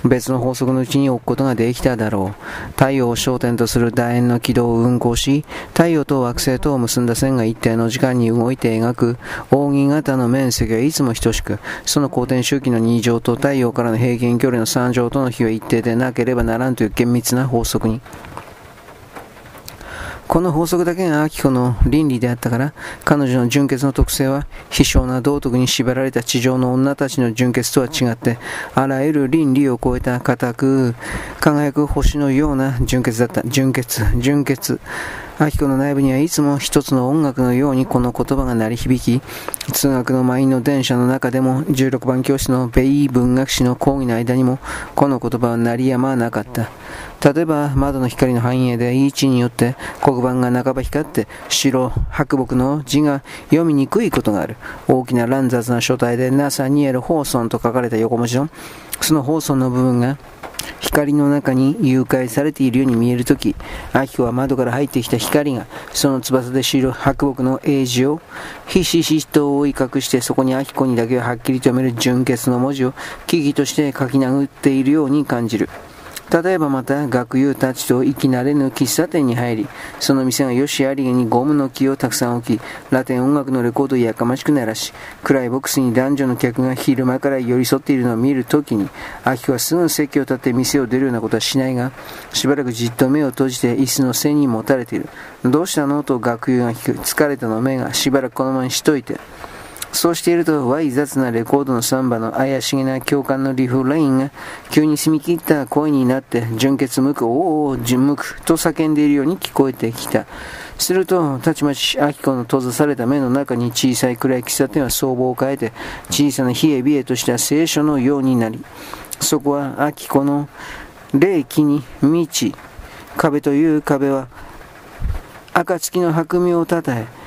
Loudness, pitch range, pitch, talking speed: -17 LUFS, 125-140 Hz, 130 Hz, 355 characters per minute